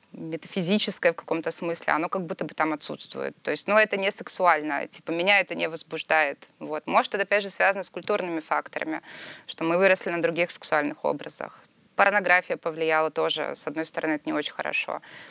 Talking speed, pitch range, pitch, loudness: 185 wpm, 160-195 Hz, 170 Hz, -26 LUFS